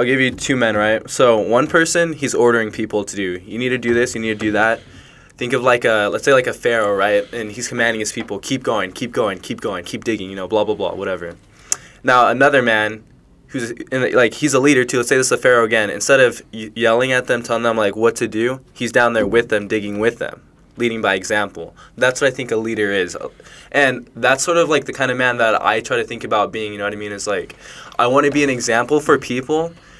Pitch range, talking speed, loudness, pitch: 110-130 Hz, 265 wpm, -17 LUFS, 115 Hz